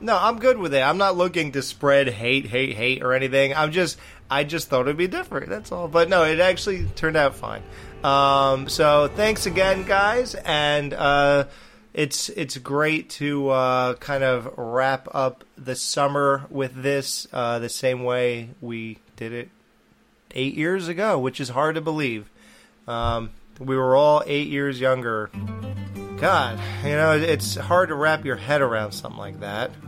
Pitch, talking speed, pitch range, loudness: 135 Hz, 175 wpm, 125-155 Hz, -22 LUFS